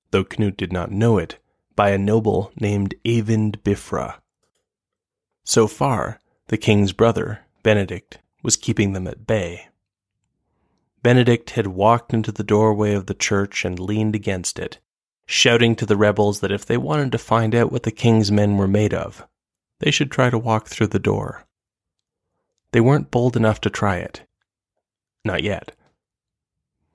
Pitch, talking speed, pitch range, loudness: 110 Hz, 160 wpm, 100-115 Hz, -20 LUFS